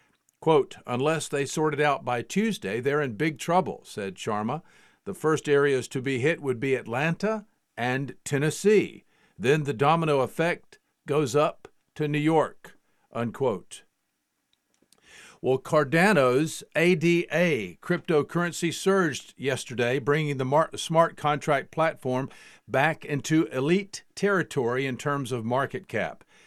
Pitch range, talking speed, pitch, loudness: 135-165 Hz, 125 wpm, 150 Hz, -26 LUFS